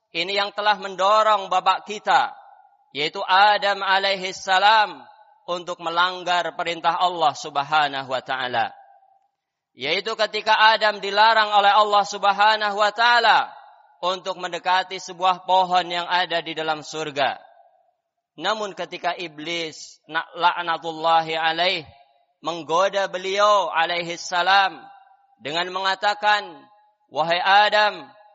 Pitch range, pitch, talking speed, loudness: 170-215 Hz, 190 Hz, 100 wpm, -21 LUFS